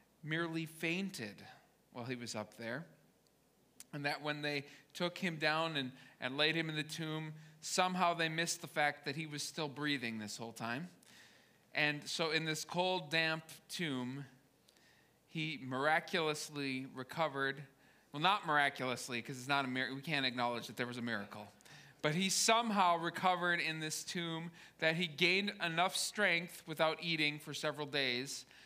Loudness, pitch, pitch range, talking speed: -37 LUFS, 155 Hz, 135-165 Hz, 160 wpm